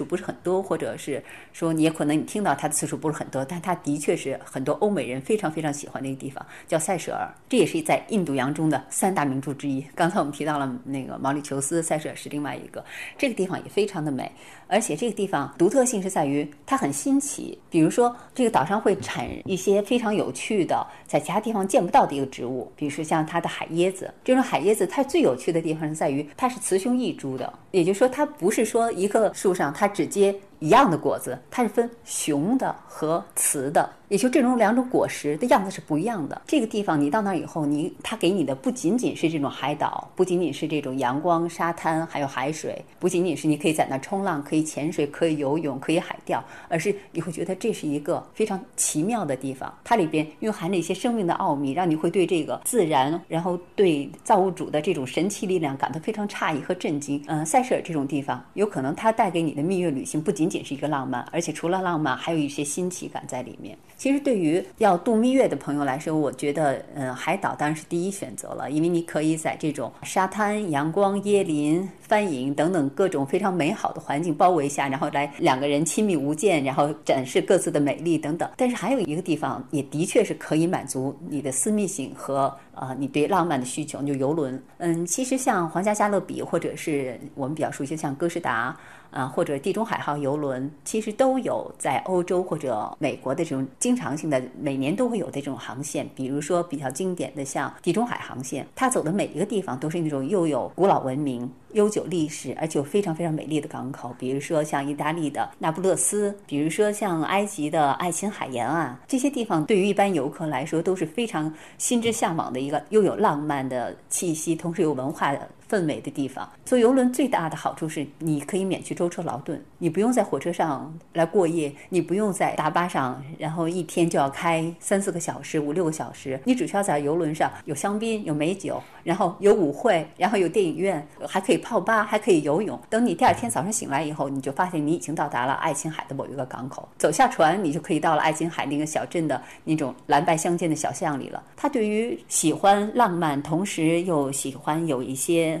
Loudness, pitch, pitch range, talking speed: -25 LUFS, 160 Hz, 145-195 Hz, 340 characters per minute